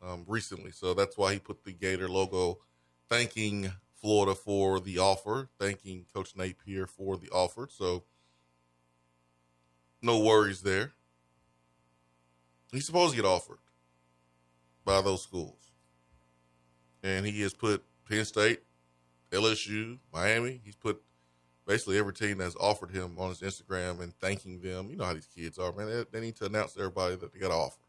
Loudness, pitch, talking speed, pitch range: -32 LUFS, 95 Hz, 160 wpm, 60-100 Hz